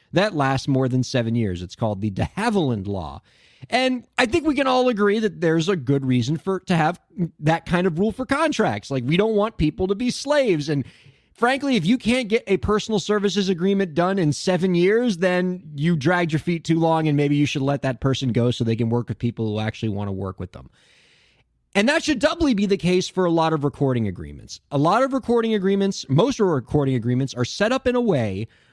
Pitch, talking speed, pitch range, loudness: 170 Hz, 230 wpm, 130-205 Hz, -21 LUFS